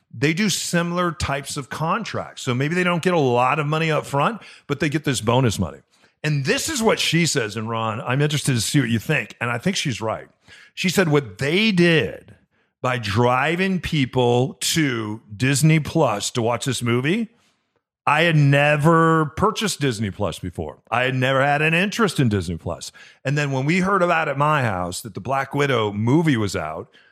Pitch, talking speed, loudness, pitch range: 145 Hz, 200 wpm, -20 LUFS, 120-165 Hz